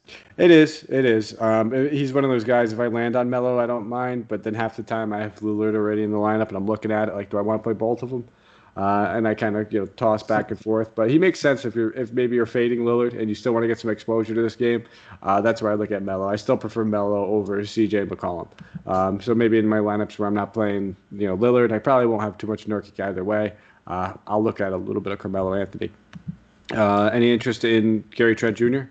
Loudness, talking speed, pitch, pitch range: -22 LUFS, 270 wpm, 110 Hz, 105-120 Hz